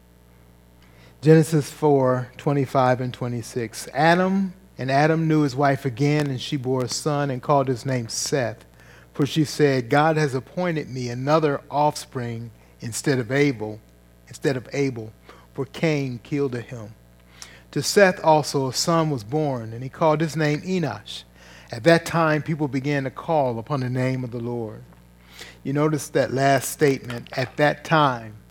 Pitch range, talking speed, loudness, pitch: 115-150 Hz, 160 wpm, -22 LUFS, 135 Hz